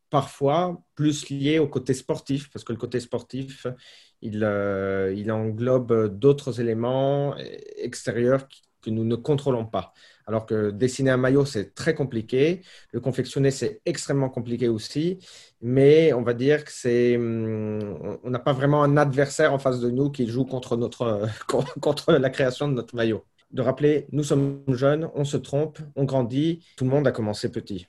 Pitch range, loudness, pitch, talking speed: 120-145 Hz, -24 LUFS, 130 Hz, 170 wpm